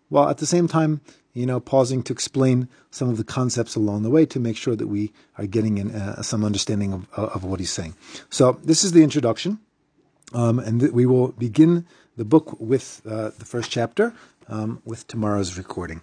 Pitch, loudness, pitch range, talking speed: 120 Hz, -22 LUFS, 110-140 Hz, 205 wpm